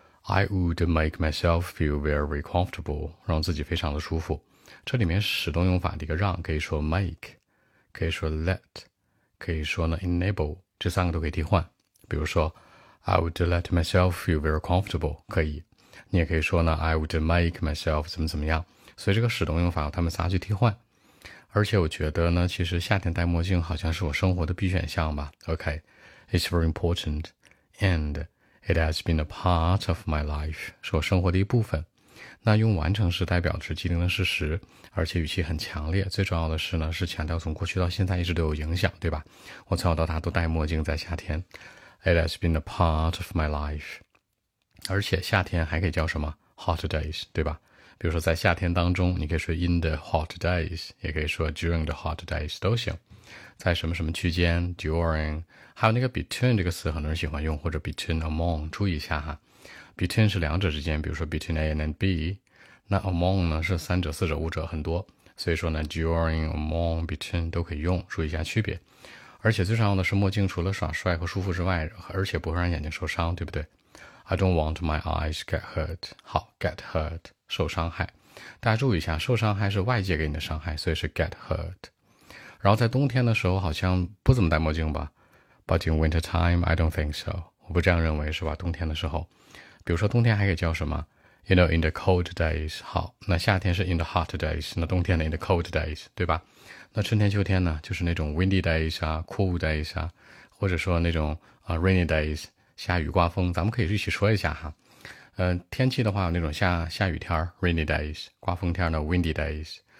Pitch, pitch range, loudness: 85 Hz, 80-95 Hz, -27 LUFS